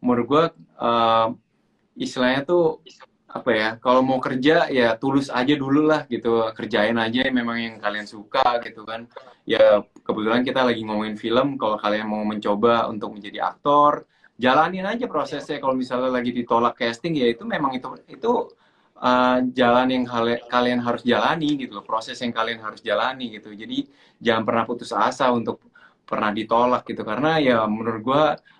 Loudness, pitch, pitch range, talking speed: -21 LUFS, 120 Hz, 115-130 Hz, 160 wpm